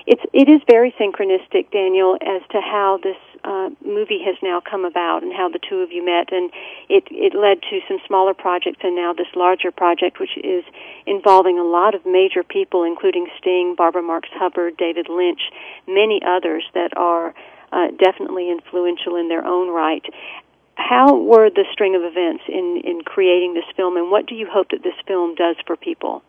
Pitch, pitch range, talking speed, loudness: 190 Hz, 175-280 Hz, 190 wpm, -18 LUFS